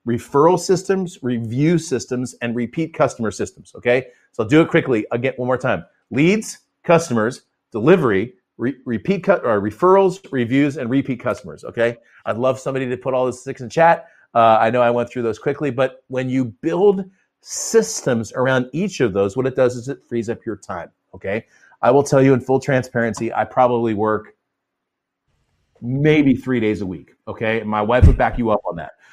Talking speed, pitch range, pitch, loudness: 190 wpm, 115-150 Hz, 130 Hz, -19 LUFS